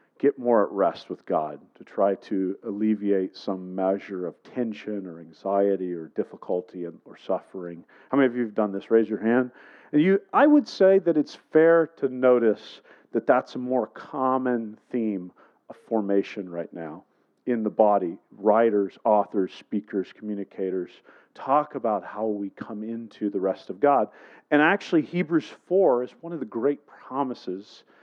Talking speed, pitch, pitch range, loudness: 165 wpm, 110 Hz, 100-130 Hz, -25 LUFS